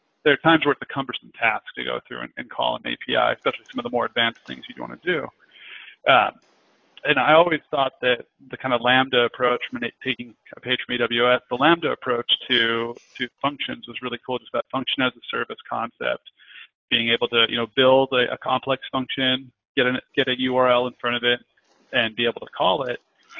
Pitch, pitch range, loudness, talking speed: 125 Hz, 120-130 Hz, -22 LUFS, 220 wpm